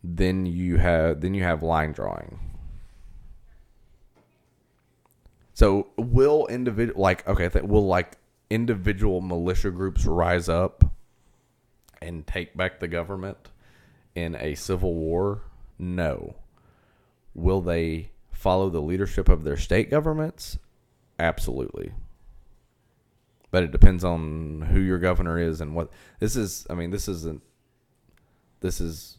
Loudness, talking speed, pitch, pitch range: -25 LUFS, 120 wpm, 90 Hz, 85-100 Hz